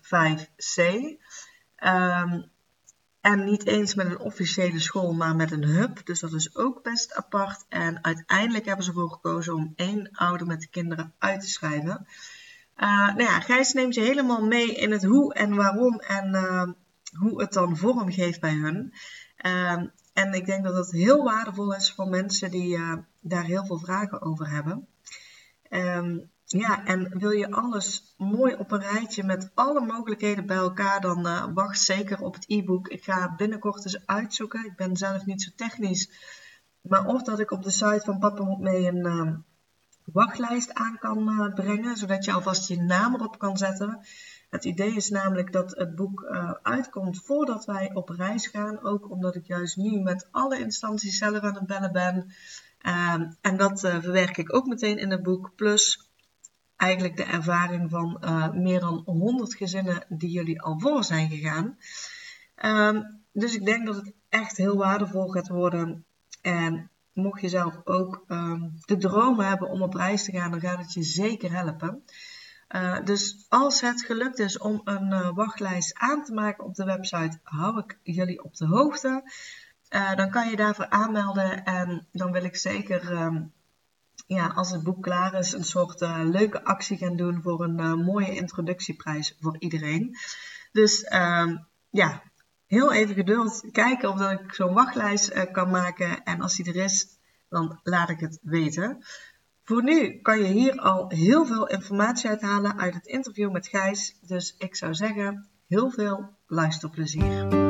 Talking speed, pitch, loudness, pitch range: 175 wpm, 195 Hz, -26 LUFS, 175-210 Hz